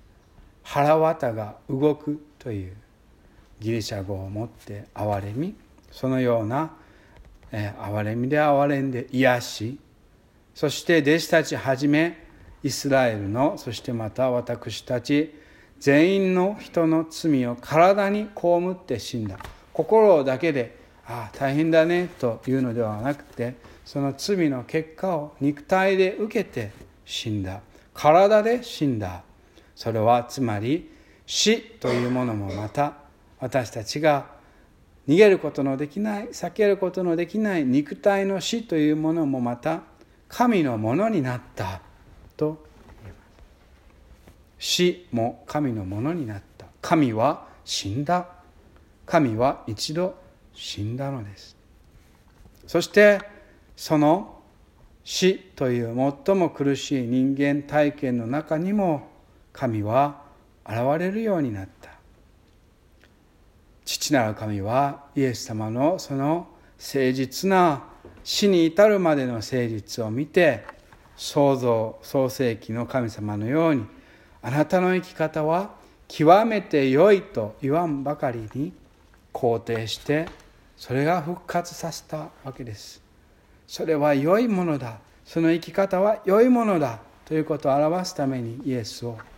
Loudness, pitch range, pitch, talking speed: -23 LUFS, 110-165 Hz, 140 Hz, 235 characters per minute